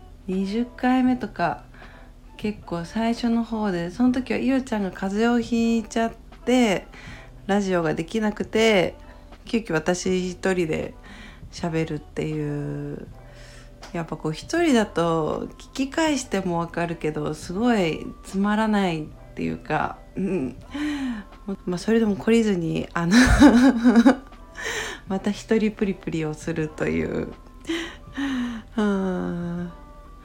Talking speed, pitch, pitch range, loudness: 225 characters per minute, 200 Hz, 170-235 Hz, -24 LUFS